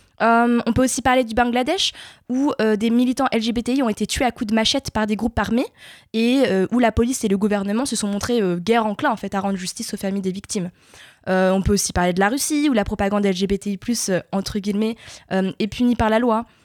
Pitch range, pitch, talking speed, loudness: 200-245 Hz, 220 Hz, 240 wpm, -20 LUFS